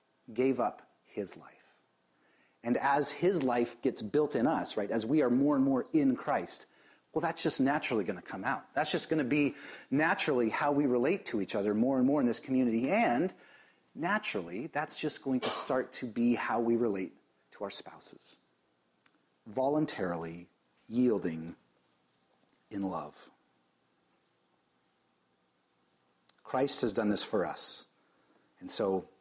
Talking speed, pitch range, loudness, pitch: 150 wpm, 95-150 Hz, -31 LUFS, 125 Hz